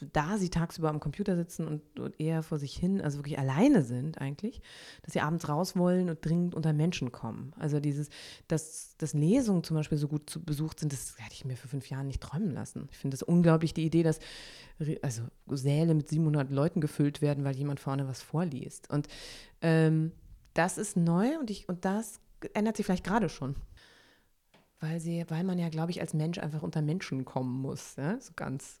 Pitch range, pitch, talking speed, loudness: 145-175 Hz, 155 Hz, 205 wpm, -32 LUFS